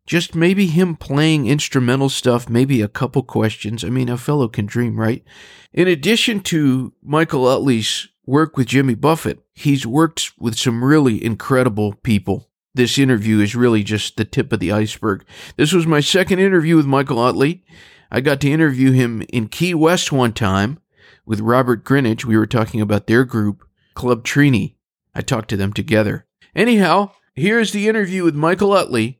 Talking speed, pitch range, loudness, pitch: 175 wpm, 110-160 Hz, -17 LUFS, 130 Hz